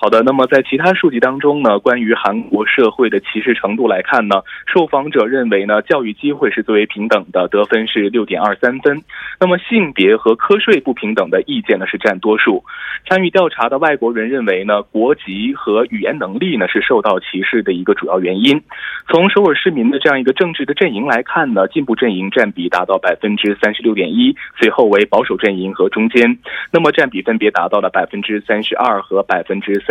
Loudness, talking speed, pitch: -14 LUFS, 325 characters per minute, 140 Hz